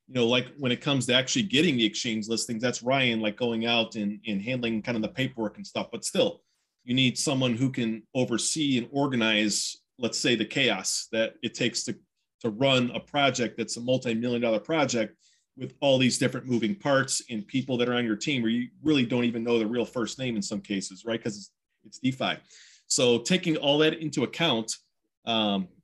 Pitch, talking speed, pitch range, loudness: 120 Hz, 210 wpm, 110-130 Hz, -27 LUFS